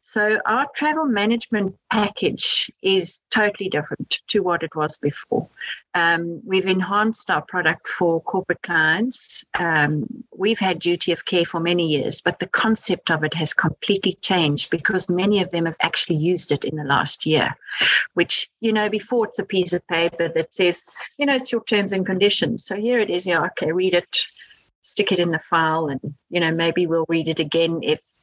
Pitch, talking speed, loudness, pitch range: 180 Hz, 195 wpm, -21 LUFS, 165-205 Hz